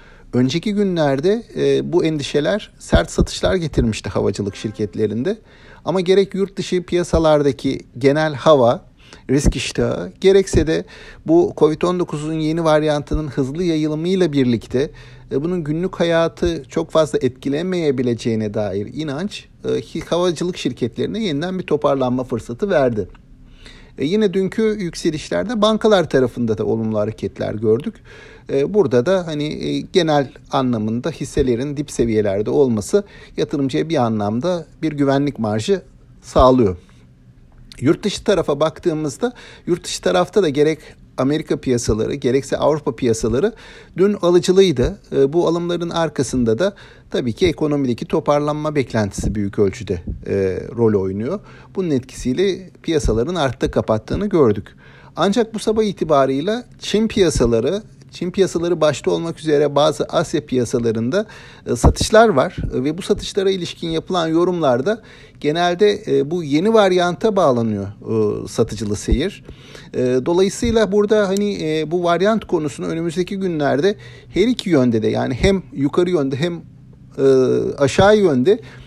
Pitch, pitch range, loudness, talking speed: 150 Hz, 125-180 Hz, -18 LUFS, 120 wpm